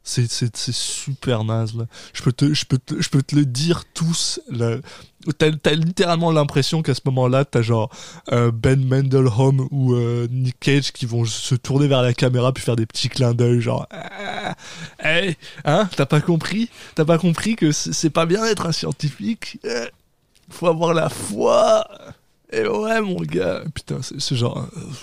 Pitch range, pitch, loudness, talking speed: 125-165 Hz, 140 Hz, -20 LUFS, 175 wpm